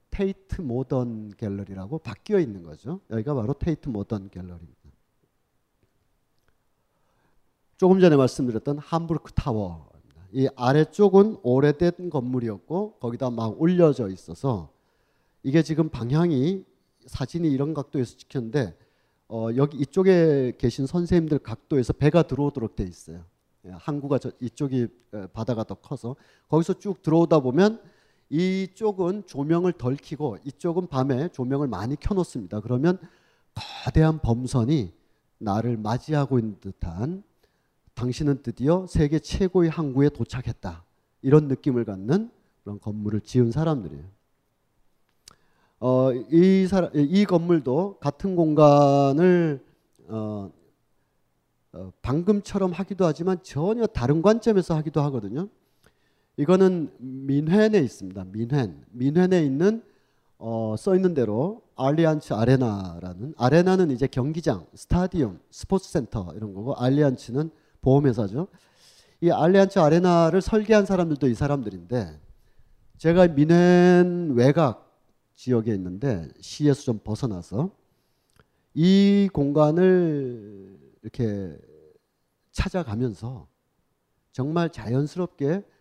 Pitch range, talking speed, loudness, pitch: 115-170 Hz, 275 characters per minute, -23 LUFS, 140 Hz